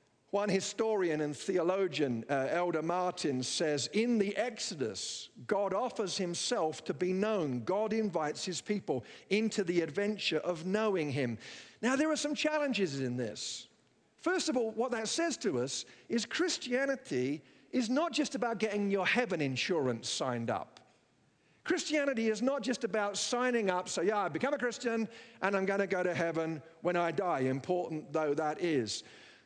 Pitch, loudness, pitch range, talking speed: 195 Hz, -33 LUFS, 160-235 Hz, 165 wpm